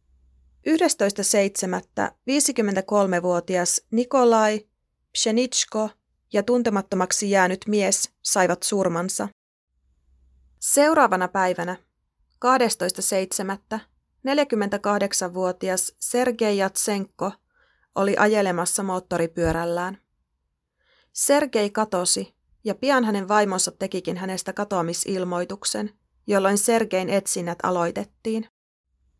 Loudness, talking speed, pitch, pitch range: -22 LUFS, 65 wpm, 195 Hz, 175-215 Hz